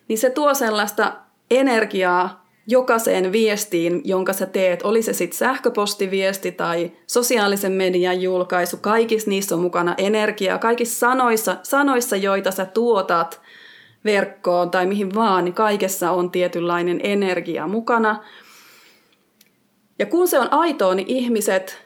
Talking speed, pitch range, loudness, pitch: 125 wpm, 180-230 Hz, -19 LUFS, 200 Hz